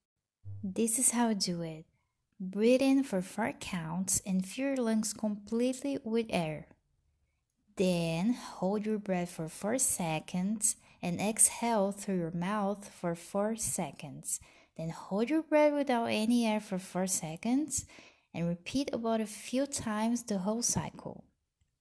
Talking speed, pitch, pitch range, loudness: 145 wpm, 205 Hz, 175-230 Hz, -31 LUFS